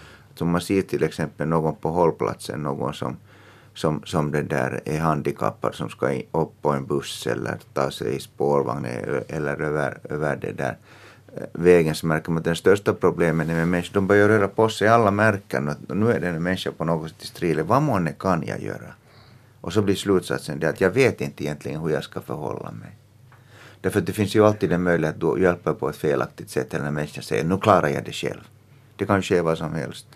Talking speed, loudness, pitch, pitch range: 210 wpm, -23 LUFS, 85 Hz, 75-105 Hz